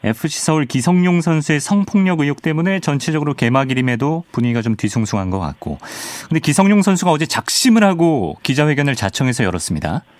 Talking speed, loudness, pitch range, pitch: 410 characters per minute, -16 LUFS, 120-170 Hz, 150 Hz